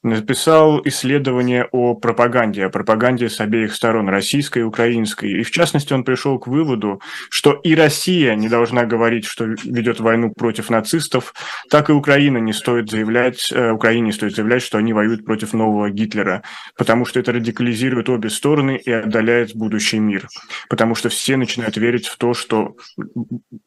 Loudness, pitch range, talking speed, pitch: -17 LUFS, 110-130 Hz, 160 wpm, 120 Hz